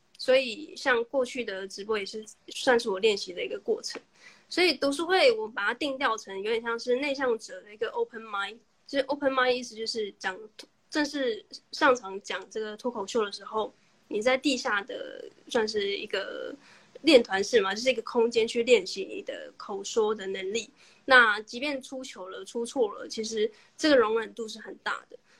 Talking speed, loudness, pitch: 300 characters per minute, -28 LUFS, 255 Hz